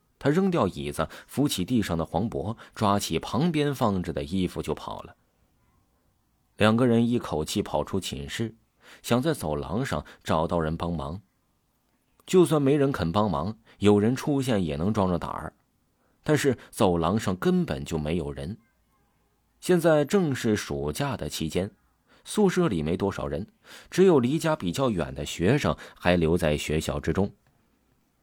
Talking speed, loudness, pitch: 225 characters per minute, -26 LUFS, 100 Hz